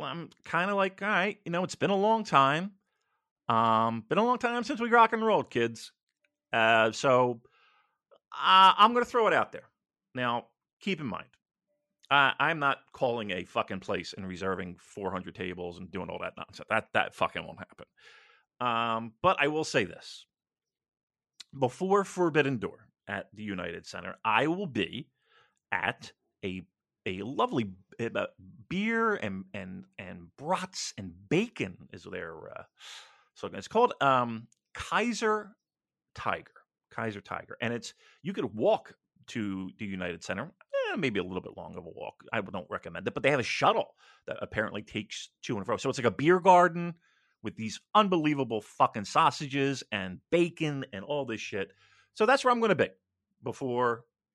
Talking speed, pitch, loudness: 170 wpm, 140 Hz, -29 LUFS